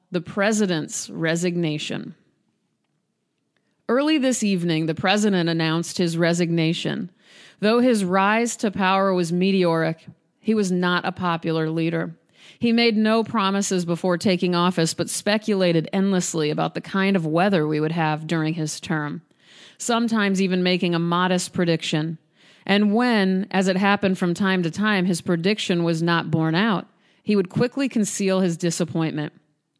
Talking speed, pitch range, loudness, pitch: 145 wpm, 165-200 Hz, -22 LUFS, 180 Hz